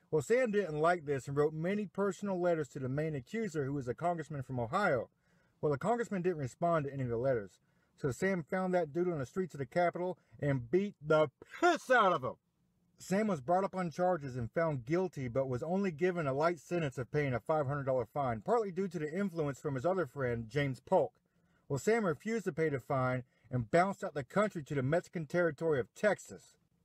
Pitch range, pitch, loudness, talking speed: 140-185 Hz, 165 Hz, -34 LUFS, 220 wpm